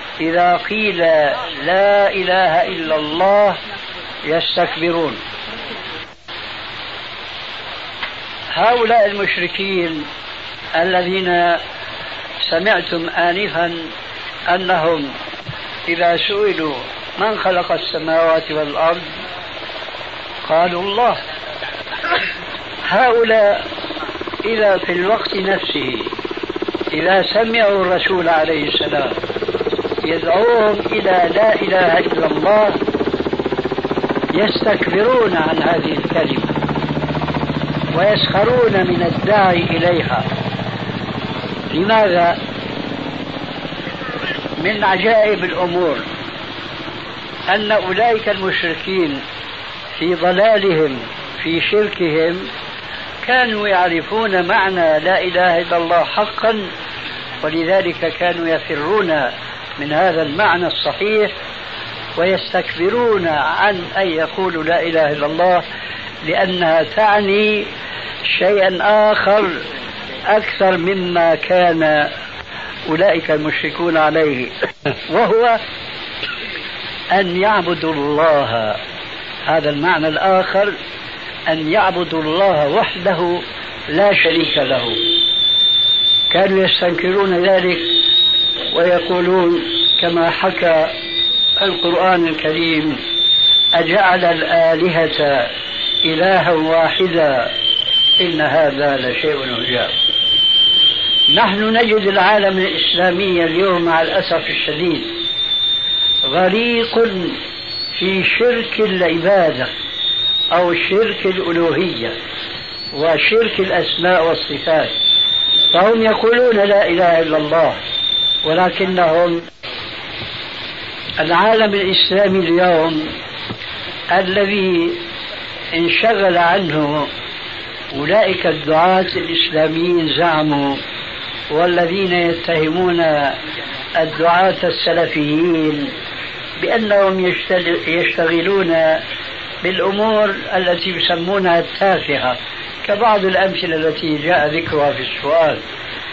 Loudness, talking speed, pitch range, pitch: -15 LUFS, 70 wpm, 165-200 Hz, 180 Hz